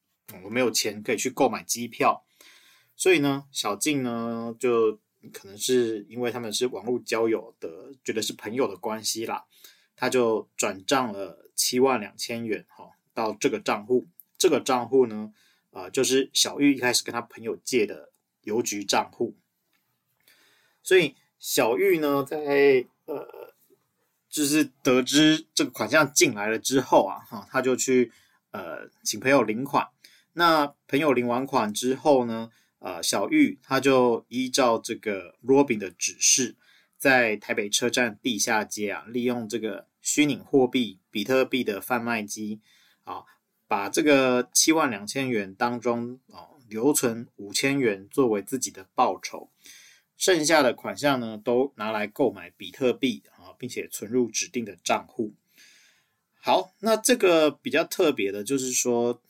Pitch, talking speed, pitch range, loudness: 125 Hz, 225 characters per minute, 115-145 Hz, -25 LUFS